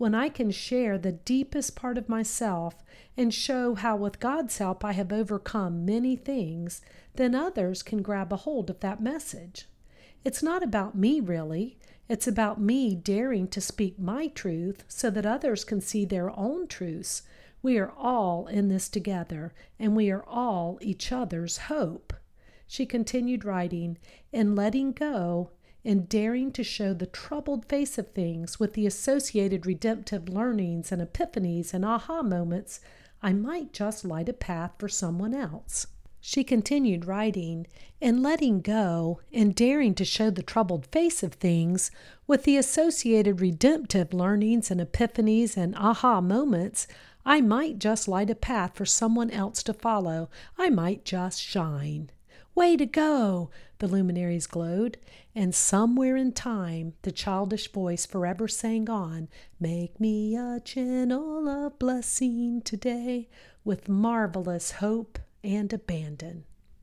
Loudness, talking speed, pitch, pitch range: -28 LUFS, 150 wpm, 215 Hz, 185-245 Hz